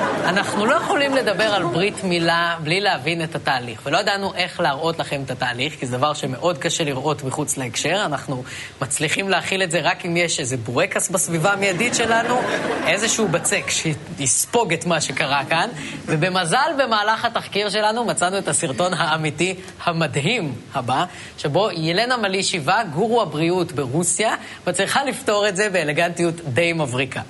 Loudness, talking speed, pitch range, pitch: -20 LUFS, 150 wpm, 150-200 Hz, 170 Hz